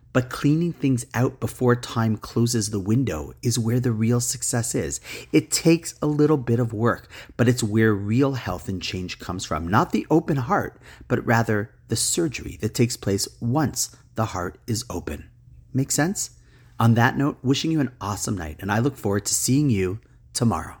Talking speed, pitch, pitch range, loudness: 185 wpm, 120 Hz, 105-130 Hz, -23 LUFS